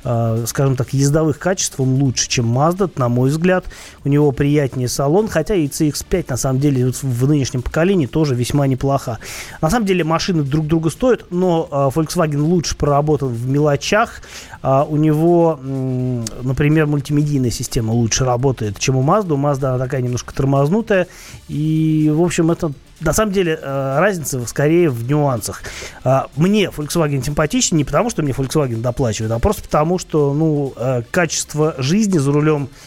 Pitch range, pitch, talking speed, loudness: 130-160 Hz, 145 Hz, 155 wpm, -17 LUFS